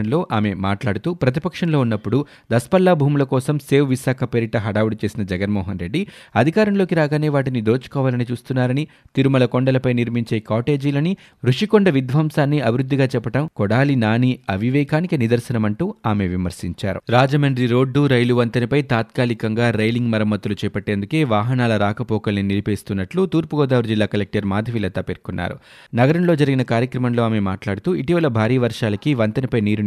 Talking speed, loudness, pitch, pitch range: 120 wpm, -19 LUFS, 125 Hz, 110-145 Hz